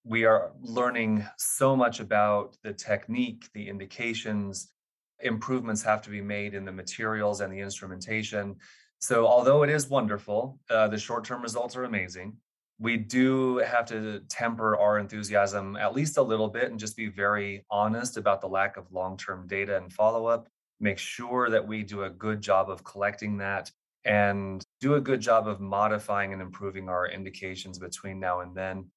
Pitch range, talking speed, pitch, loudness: 100-115 Hz, 180 wpm, 105 Hz, -28 LUFS